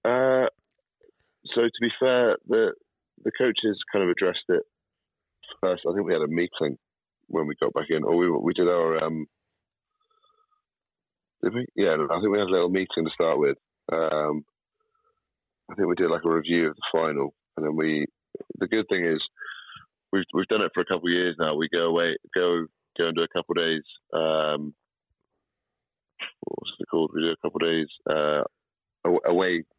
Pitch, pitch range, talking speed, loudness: 85 Hz, 80-130 Hz, 190 wpm, -25 LUFS